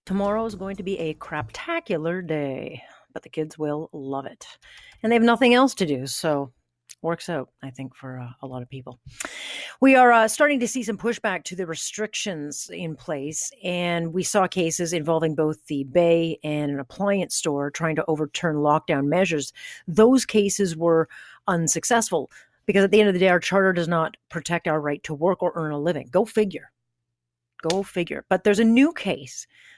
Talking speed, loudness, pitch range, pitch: 190 wpm, -23 LUFS, 150-200 Hz, 170 Hz